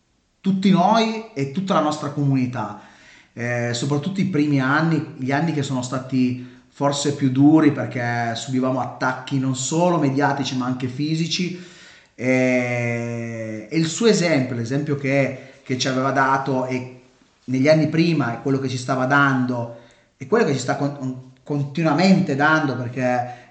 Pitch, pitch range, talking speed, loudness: 135 Hz, 125-150 Hz, 150 wpm, -21 LUFS